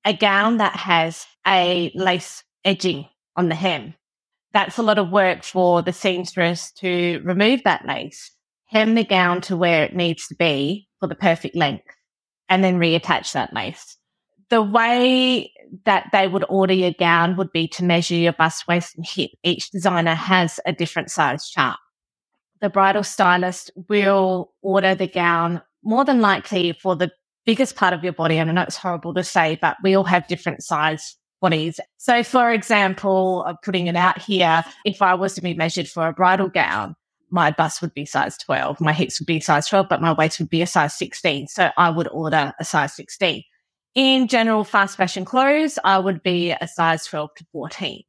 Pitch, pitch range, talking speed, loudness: 180 Hz, 170-195 Hz, 190 wpm, -19 LUFS